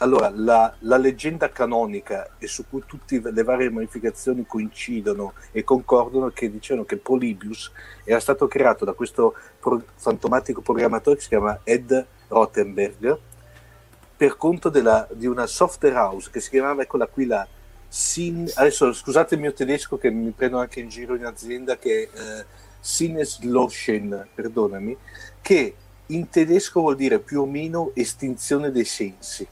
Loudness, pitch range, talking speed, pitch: -22 LUFS, 115-145 Hz, 155 wpm, 125 Hz